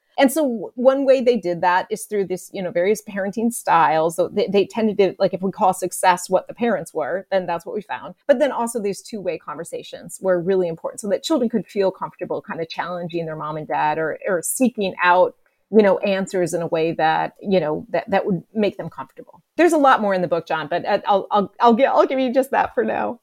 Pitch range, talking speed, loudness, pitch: 175-235 Hz, 250 wpm, -20 LUFS, 195 Hz